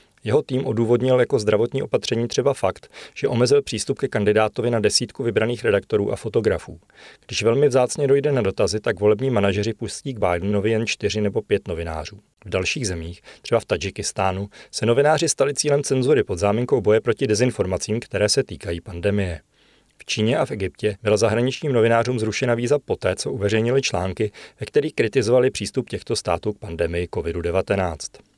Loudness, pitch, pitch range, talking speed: -21 LUFS, 110 Hz, 100-130 Hz, 165 wpm